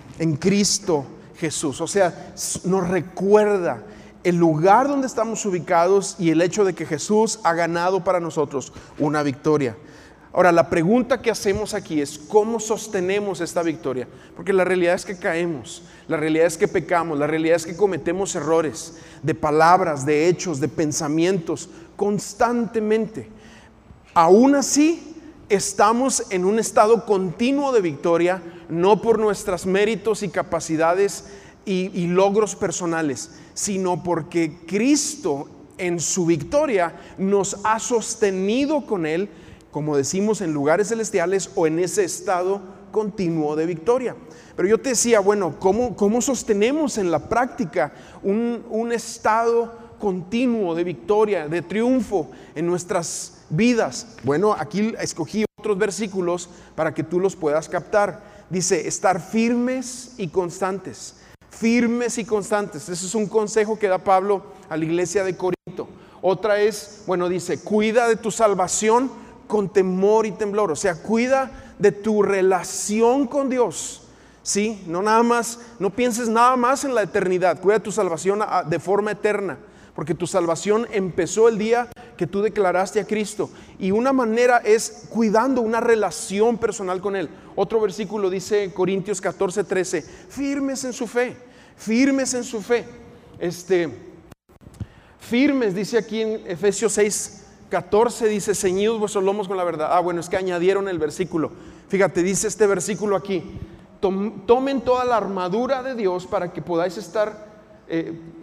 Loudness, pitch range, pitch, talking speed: -21 LUFS, 175-220 Hz, 195 Hz, 145 wpm